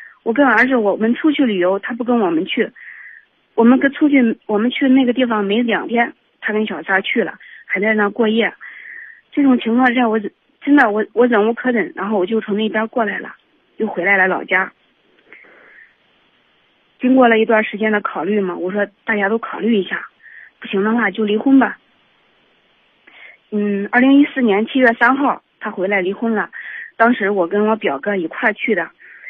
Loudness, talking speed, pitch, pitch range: -16 LUFS, 260 characters per minute, 225 Hz, 205-255 Hz